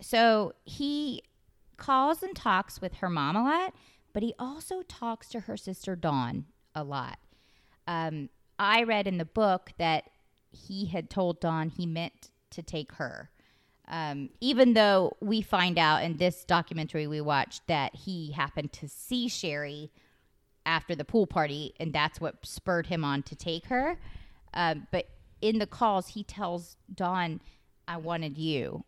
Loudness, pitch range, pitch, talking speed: -30 LUFS, 155-215 Hz, 175 Hz, 160 wpm